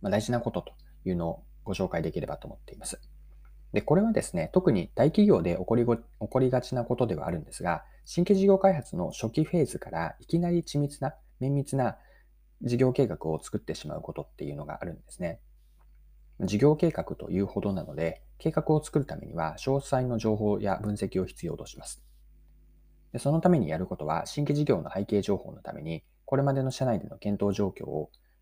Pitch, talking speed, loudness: 105 Hz, 380 characters per minute, -29 LUFS